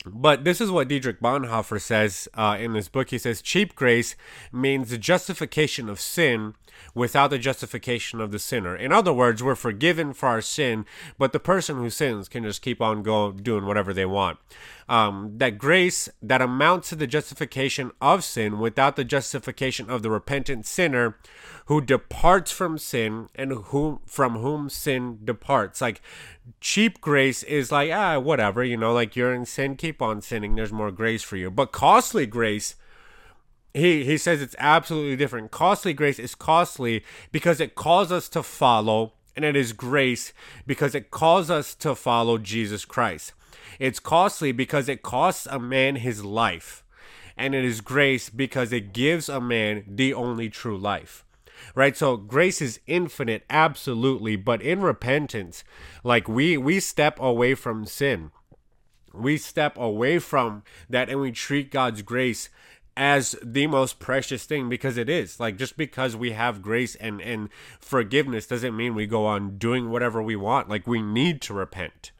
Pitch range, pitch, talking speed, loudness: 110-140 Hz, 125 Hz, 170 wpm, -24 LUFS